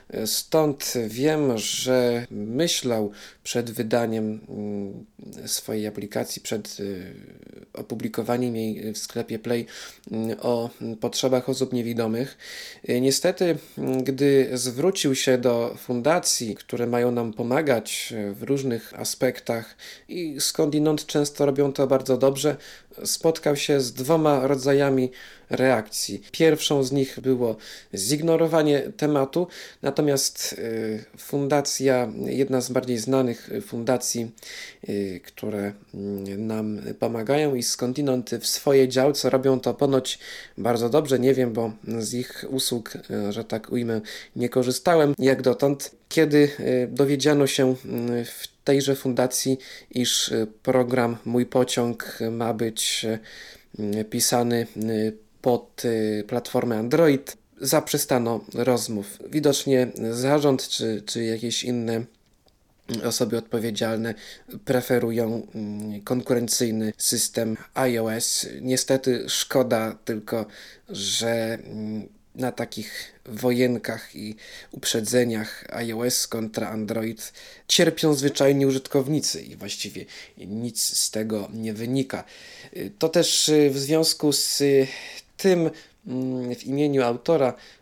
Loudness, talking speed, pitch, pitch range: -24 LUFS, 100 wpm, 125 Hz, 115-140 Hz